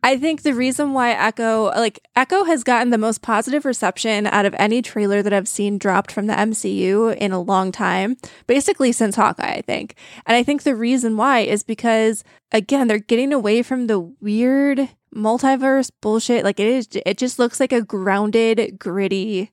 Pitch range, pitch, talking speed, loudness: 205-255 Hz, 225 Hz, 190 wpm, -18 LUFS